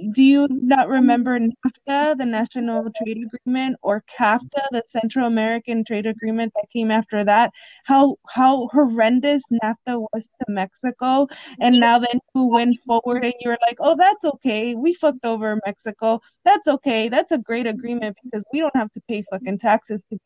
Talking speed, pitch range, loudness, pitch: 170 wpm, 225-265 Hz, -20 LUFS, 240 Hz